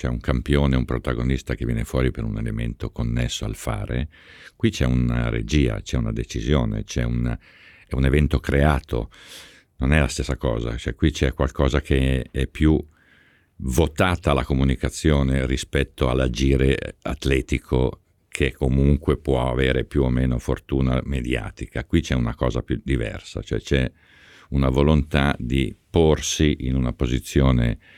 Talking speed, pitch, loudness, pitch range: 150 wpm, 65 Hz, -23 LUFS, 65-75 Hz